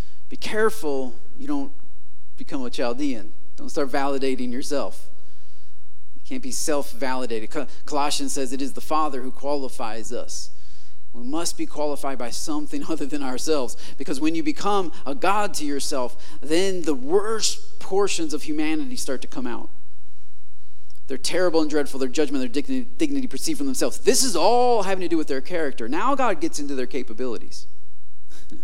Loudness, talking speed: -26 LUFS, 165 wpm